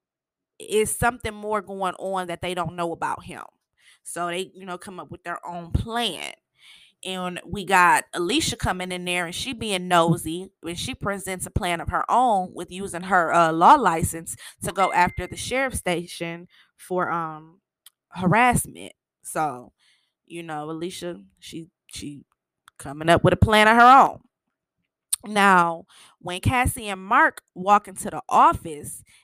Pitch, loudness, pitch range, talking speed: 180 Hz, -22 LUFS, 170-200 Hz, 160 wpm